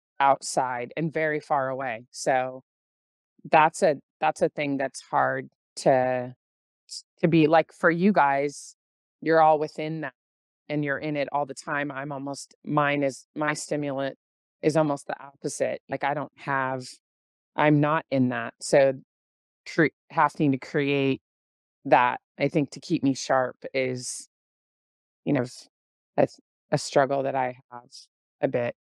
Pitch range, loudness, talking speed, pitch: 125-150 Hz, -25 LUFS, 150 wpm, 135 Hz